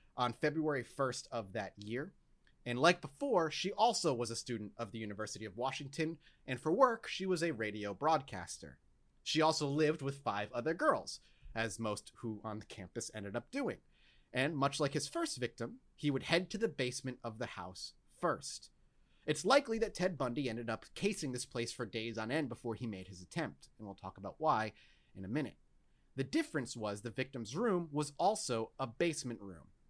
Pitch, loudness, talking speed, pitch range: 130 Hz, -37 LUFS, 195 wpm, 110-160 Hz